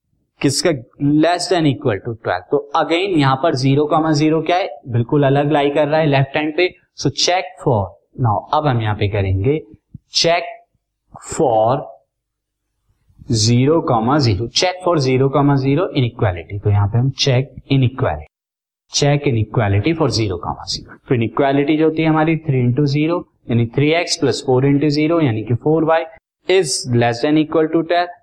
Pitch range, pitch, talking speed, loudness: 120-160 Hz, 145 Hz, 165 wpm, -17 LUFS